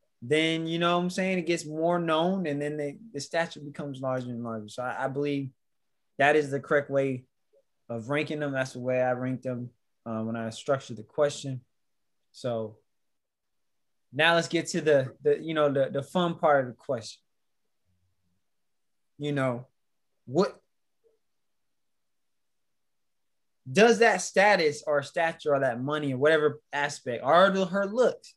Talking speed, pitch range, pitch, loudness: 165 wpm, 130-165 Hz, 145 Hz, -27 LUFS